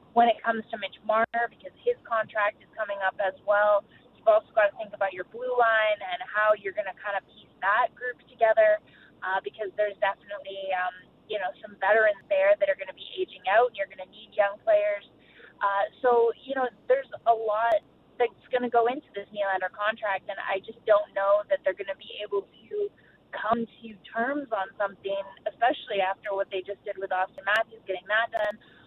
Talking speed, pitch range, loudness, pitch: 210 wpm, 200-250 Hz, -27 LUFS, 215 Hz